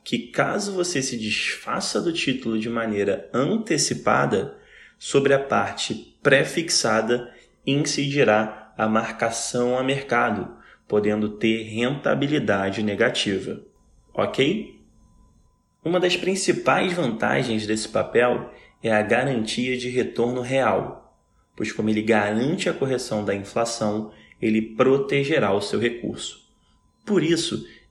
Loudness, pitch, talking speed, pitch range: -23 LUFS, 115 Hz, 110 wpm, 110-135 Hz